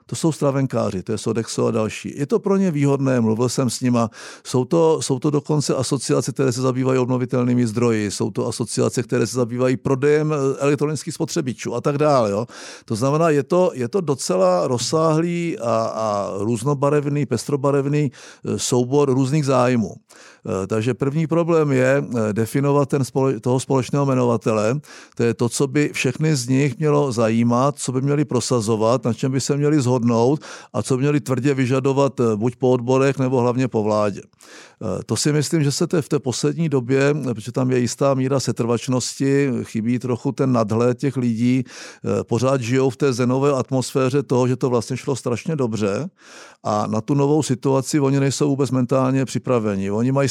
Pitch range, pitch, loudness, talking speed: 120-145 Hz, 130 Hz, -20 LUFS, 175 wpm